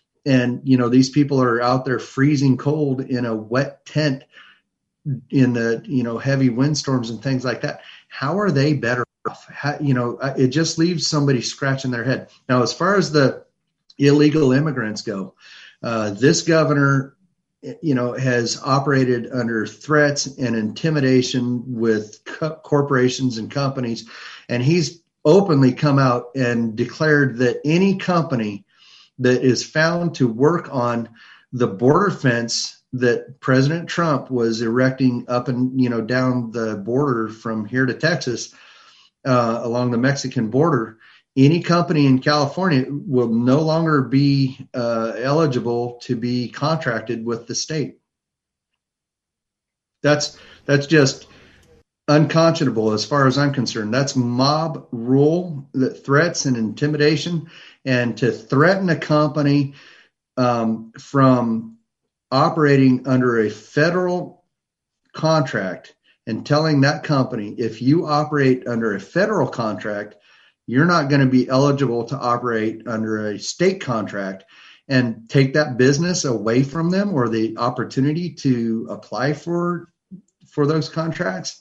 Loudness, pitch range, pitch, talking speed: -19 LUFS, 120-150 Hz, 130 Hz, 135 wpm